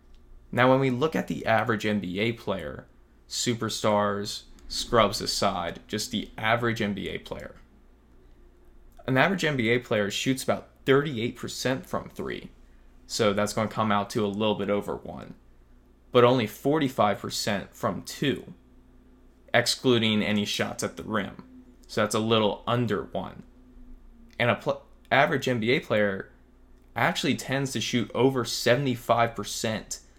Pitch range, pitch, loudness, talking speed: 100-120 Hz, 110 Hz, -26 LUFS, 135 wpm